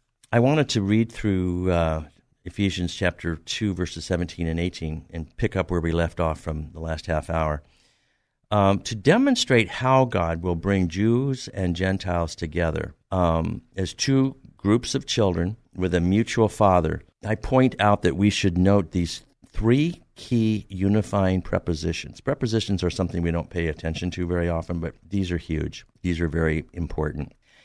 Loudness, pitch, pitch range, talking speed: -24 LUFS, 90 Hz, 85-110 Hz, 165 wpm